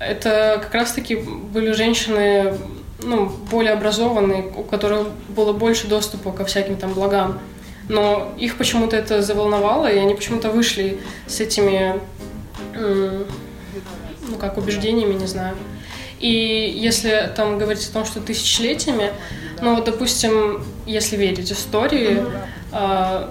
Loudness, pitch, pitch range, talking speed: -19 LUFS, 210 Hz, 195-220 Hz, 120 wpm